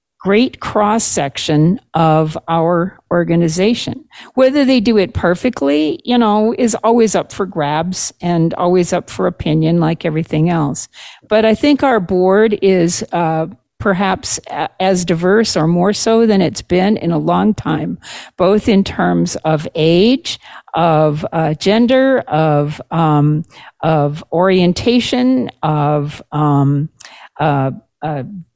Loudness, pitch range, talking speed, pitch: -14 LUFS, 155-215 Hz, 130 wpm, 175 Hz